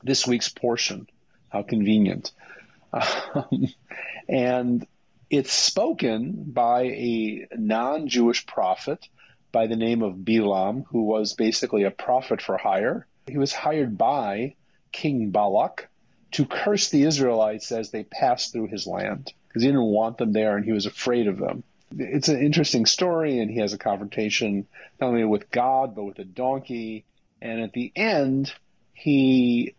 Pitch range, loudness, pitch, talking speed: 110-130 Hz, -24 LUFS, 120 Hz, 155 wpm